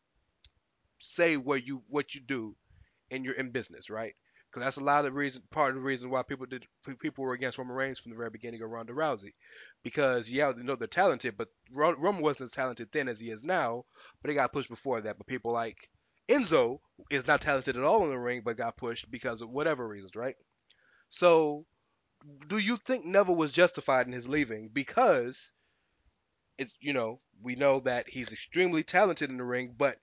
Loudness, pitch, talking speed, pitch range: -31 LUFS, 135 Hz, 210 wpm, 120-145 Hz